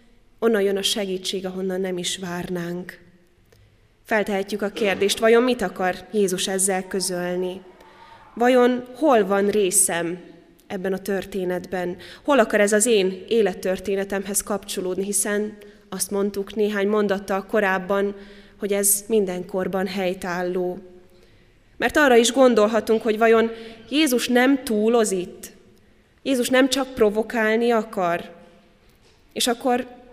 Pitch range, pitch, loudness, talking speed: 185-225 Hz, 200 Hz, -21 LUFS, 115 wpm